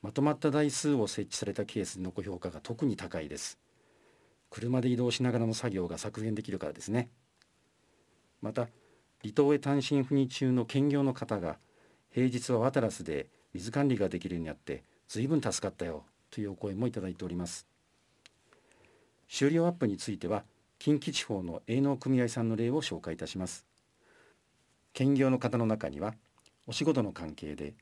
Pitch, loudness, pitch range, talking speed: 115 Hz, -32 LUFS, 95-135 Hz, 330 characters per minute